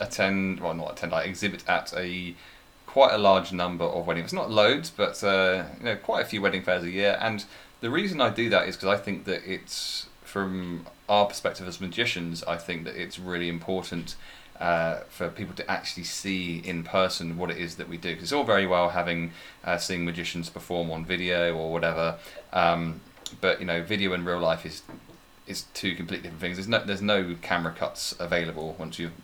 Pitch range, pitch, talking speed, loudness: 85-95 Hz, 90 Hz, 210 wpm, -27 LUFS